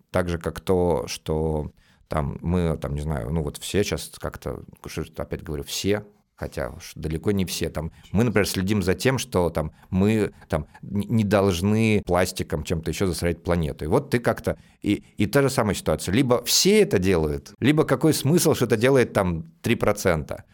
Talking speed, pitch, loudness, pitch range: 180 wpm, 95 Hz, -24 LUFS, 80-110 Hz